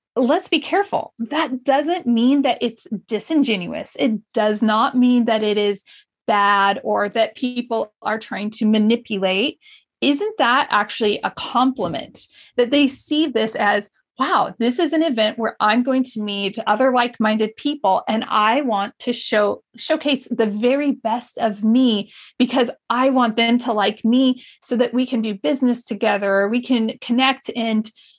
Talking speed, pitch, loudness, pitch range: 160 wpm, 235 Hz, -19 LUFS, 215-265 Hz